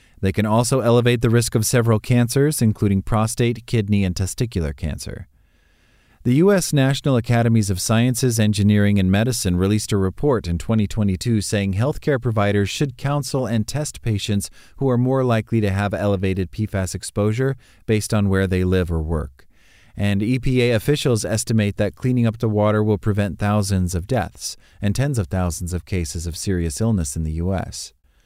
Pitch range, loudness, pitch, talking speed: 95-120 Hz, -20 LUFS, 105 Hz, 170 wpm